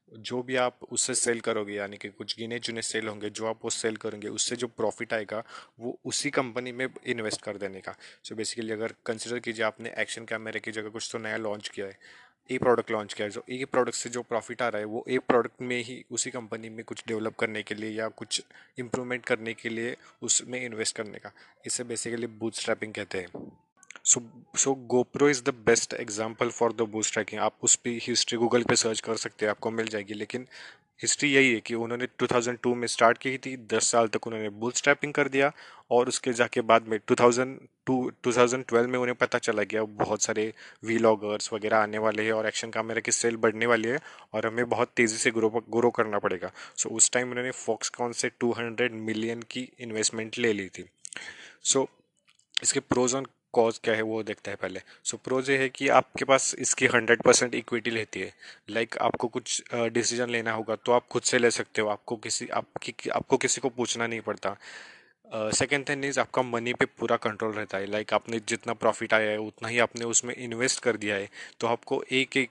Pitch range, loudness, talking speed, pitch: 110-125 Hz, -28 LUFS, 215 wpm, 115 Hz